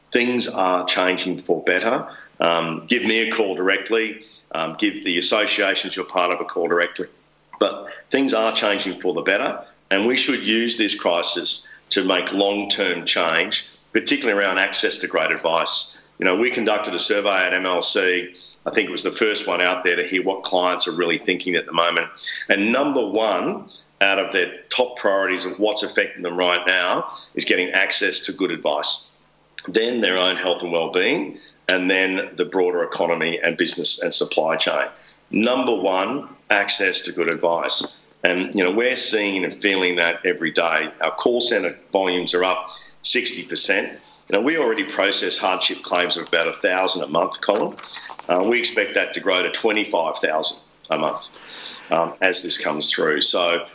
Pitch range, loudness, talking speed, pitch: 90-110 Hz, -20 LUFS, 180 wpm, 95 Hz